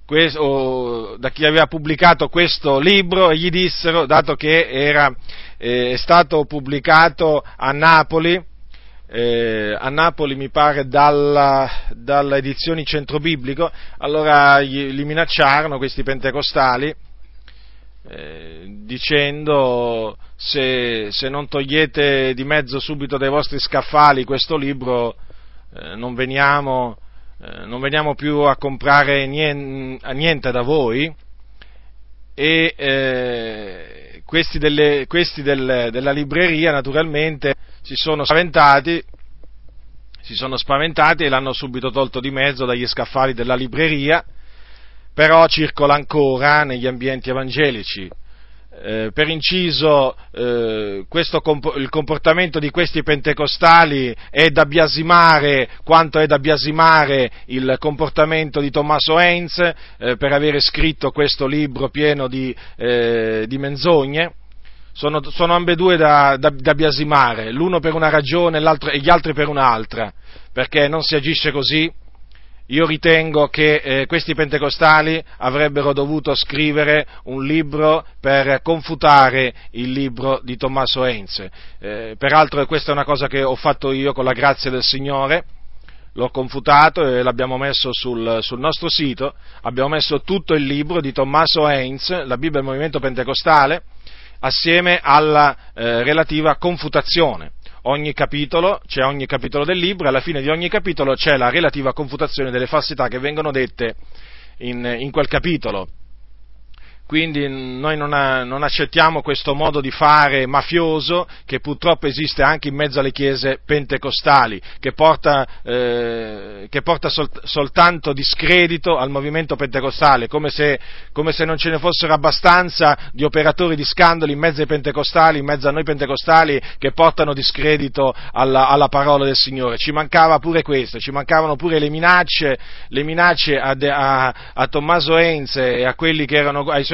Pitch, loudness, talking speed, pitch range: 145 Hz, -16 LUFS, 140 wpm, 130-155 Hz